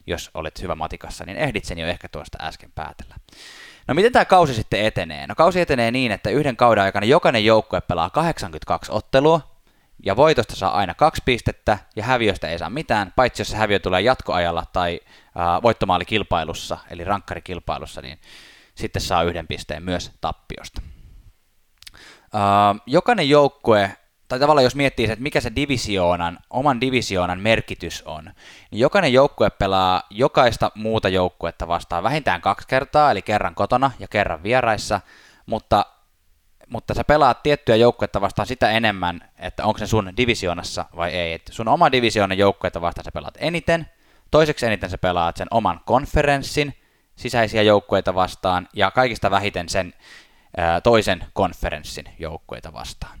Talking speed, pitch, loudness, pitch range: 150 wpm, 100 Hz, -20 LUFS, 90-120 Hz